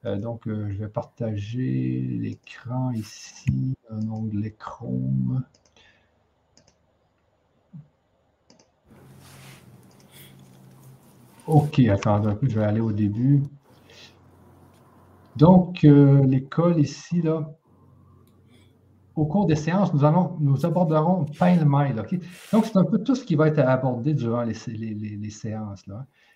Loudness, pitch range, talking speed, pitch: -23 LUFS, 105-150 Hz, 120 wpm, 120 Hz